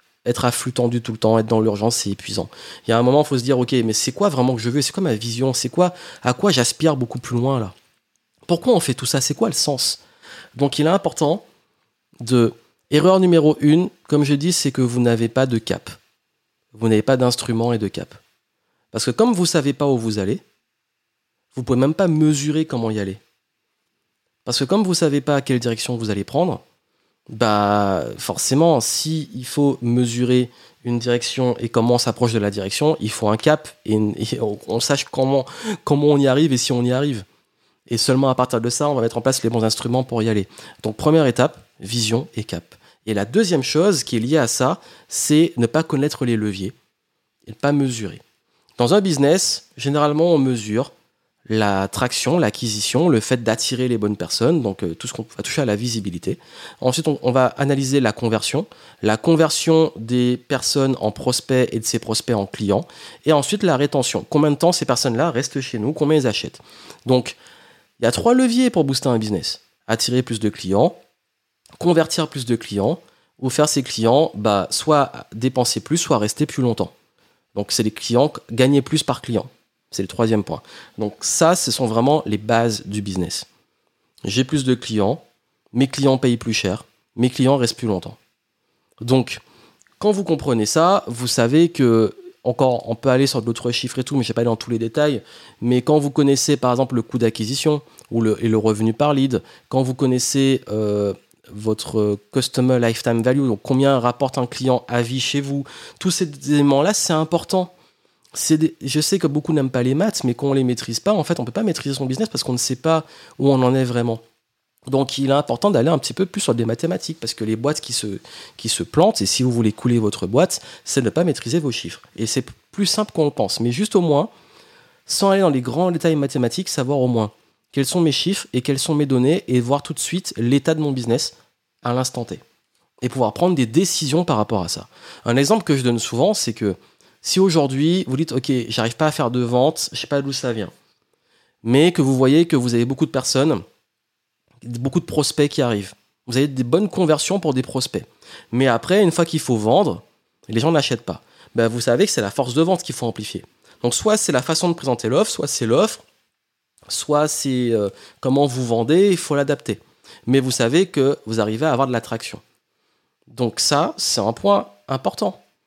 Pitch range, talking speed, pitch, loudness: 115-150 Hz, 215 wpm, 130 Hz, -19 LUFS